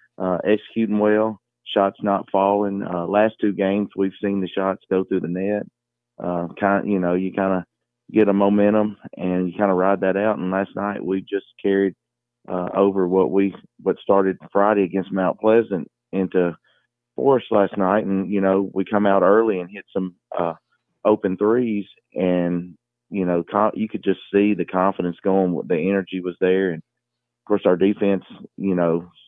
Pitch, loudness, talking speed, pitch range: 95 Hz, -21 LUFS, 185 wpm, 90-100 Hz